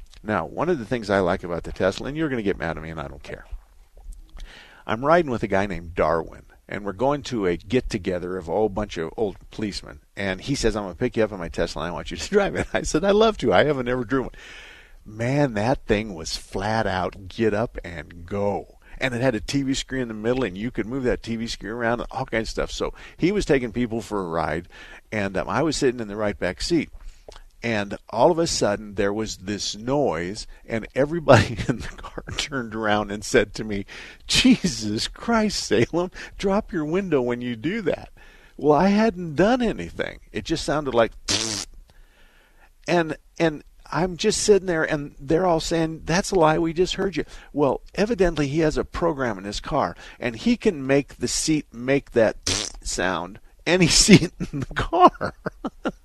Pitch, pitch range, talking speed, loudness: 120 Hz, 100-155 Hz, 220 wpm, -23 LUFS